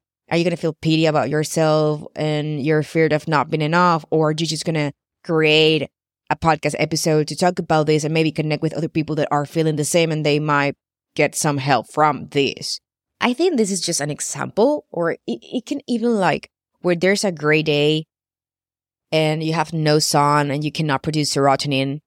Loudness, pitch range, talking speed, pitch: -19 LUFS, 150-165 Hz, 200 wpm, 155 Hz